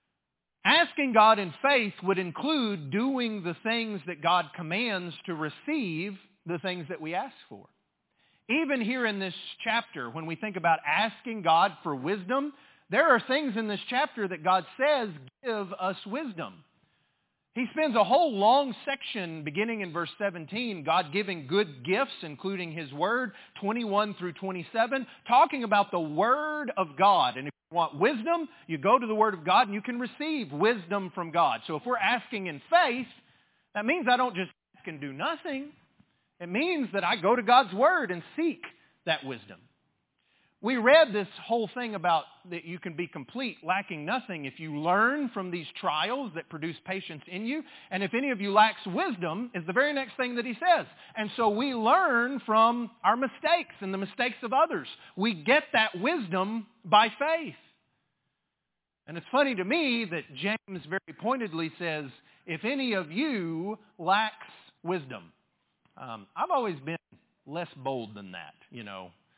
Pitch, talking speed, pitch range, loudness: 210 Hz, 175 wpm, 175-250 Hz, -28 LUFS